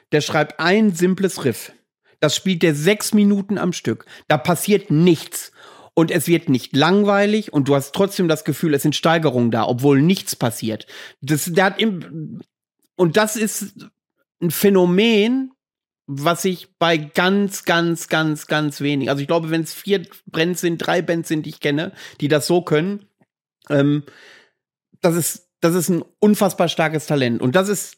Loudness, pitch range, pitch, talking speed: -18 LUFS, 150-195 Hz, 170 Hz, 170 wpm